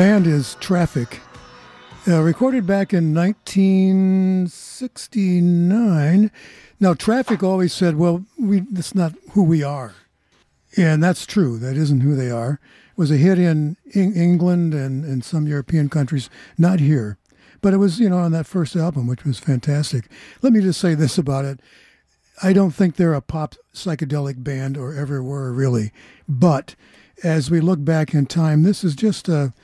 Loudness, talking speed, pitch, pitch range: -19 LUFS, 170 wpm, 165 Hz, 140-190 Hz